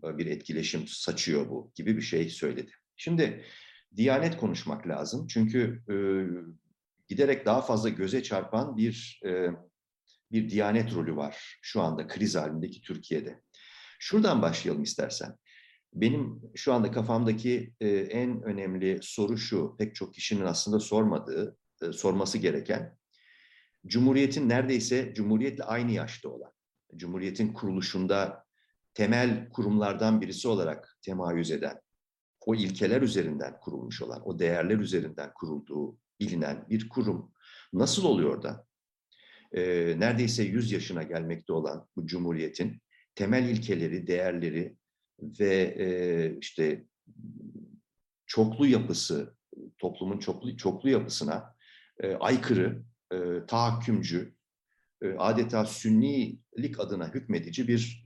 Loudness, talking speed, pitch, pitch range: -30 LUFS, 115 wpm, 110 Hz, 90-120 Hz